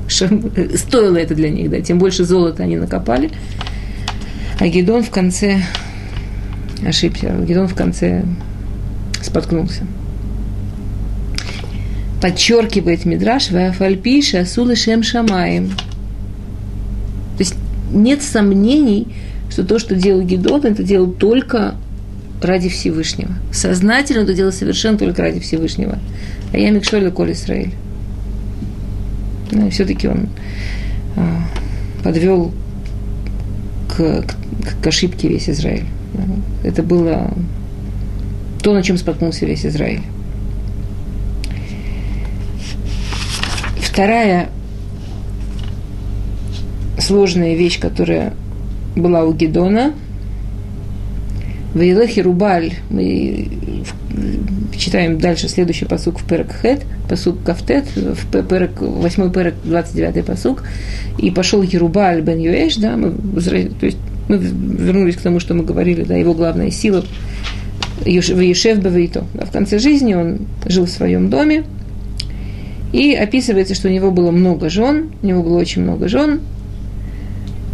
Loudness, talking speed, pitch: -16 LUFS, 105 wpm, 100 Hz